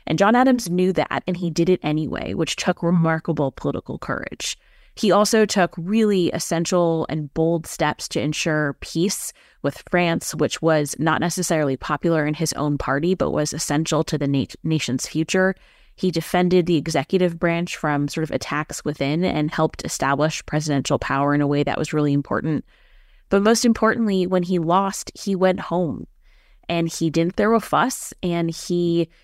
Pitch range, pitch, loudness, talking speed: 150-180 Hz, 165 Hz, -21 LUFS, 170 wpm